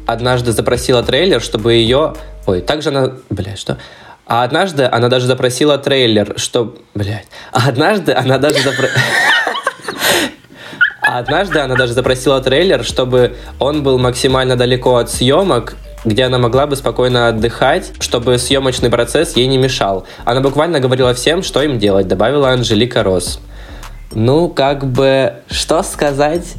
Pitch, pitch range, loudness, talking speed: 130 Hz, 120-135 Hz, -13 LUFS, 140 wpm